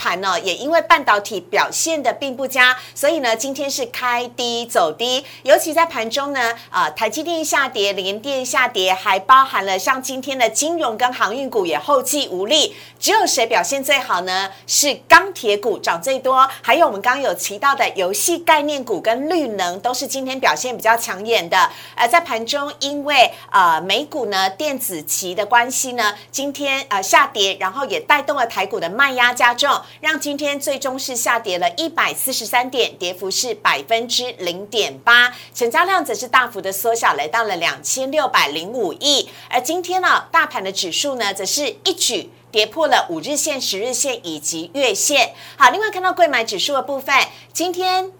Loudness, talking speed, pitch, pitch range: -17 LUFS, 285 characters per minute, 265 Hz, 230-305 Hz